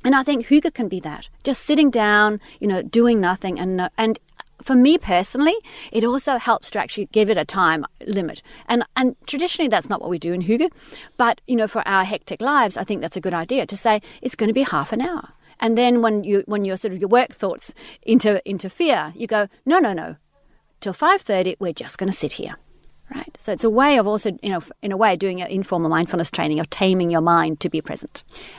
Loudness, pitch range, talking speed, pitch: -20 LUFS, 185-250 Hz, 235 wpm, 215 Hz